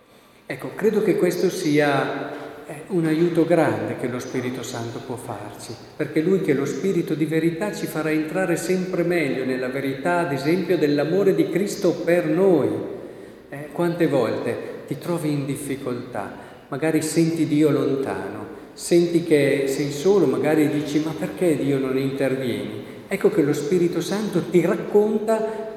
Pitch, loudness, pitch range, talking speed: 155 Hz, -22 LUFS, 140-175 Hz, 155 wpm